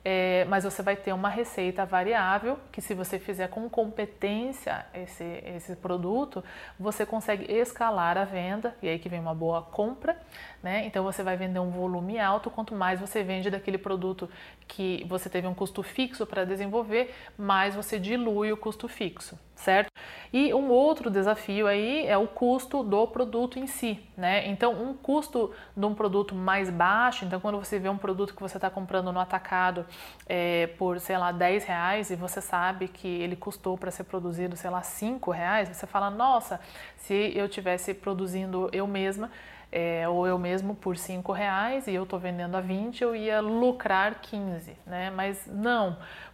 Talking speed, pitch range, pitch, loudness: 180 wpm, 185-220 Hz, 195 Hz, -29 LUFS